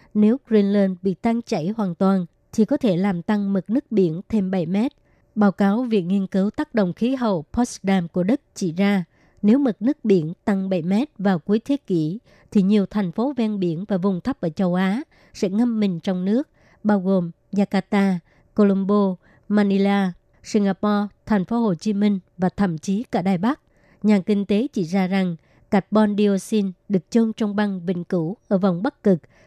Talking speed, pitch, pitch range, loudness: 195 wpm, 200 Hz, 190-215 Hz, -22 LUFS